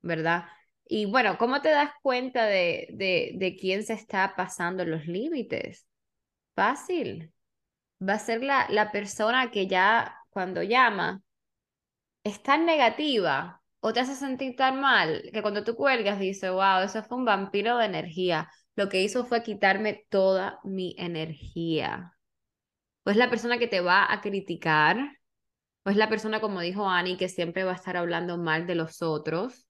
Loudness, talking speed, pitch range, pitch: -26 LUFS, 165 wpm, 180-240 Hz, 200 Hz